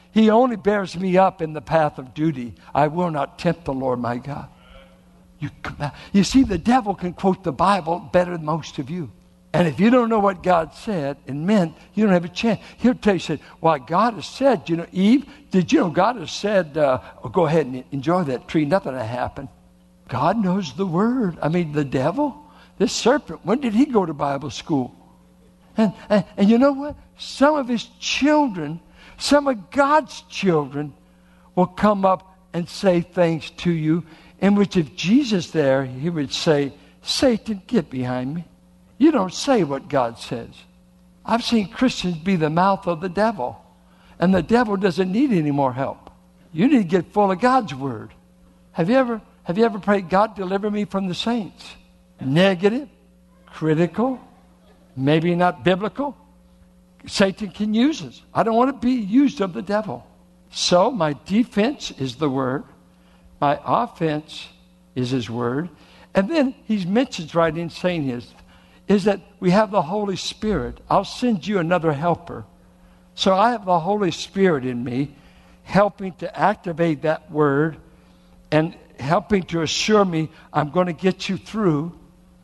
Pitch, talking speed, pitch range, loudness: 175 Hz, 175 wpm, 145-205 Hz, -21 LUFS